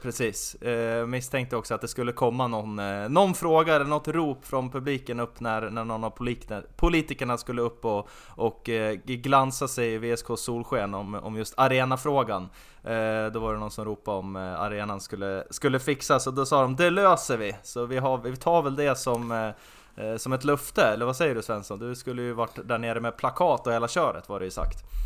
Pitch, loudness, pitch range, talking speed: 120 Hz, -27 LUFS, 110-135 Hz, 200 wpm